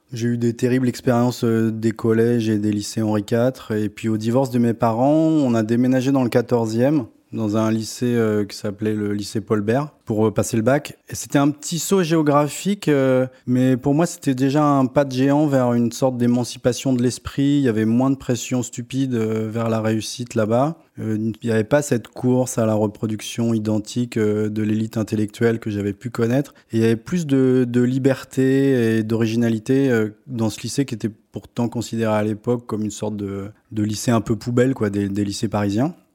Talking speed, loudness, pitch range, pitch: 210 wpm, -20 LUFS, 110-130 Hz, 115 Hz